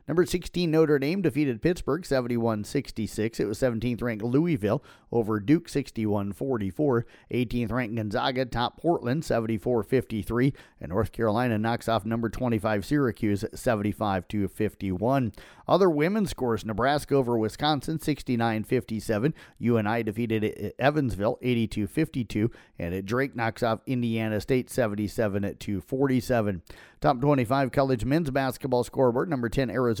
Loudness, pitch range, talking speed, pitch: -27 LUFS, 110-135 Hz, 115 wpm, 120 Hz